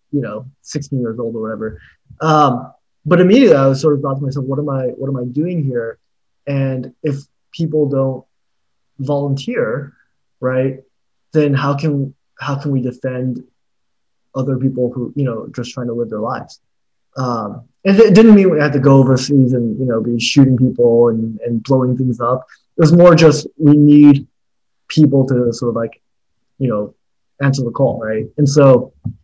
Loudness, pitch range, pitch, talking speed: -14 LUFS, 120-145 Hz, 130 Hz, 185 wpm